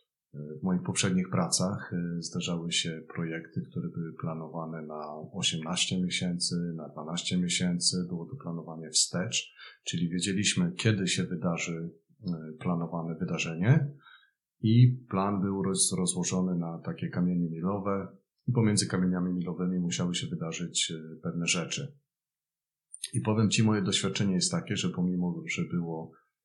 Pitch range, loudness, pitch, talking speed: 85-100 Hz, -30 LUFS, 90 Hz, 125 wpm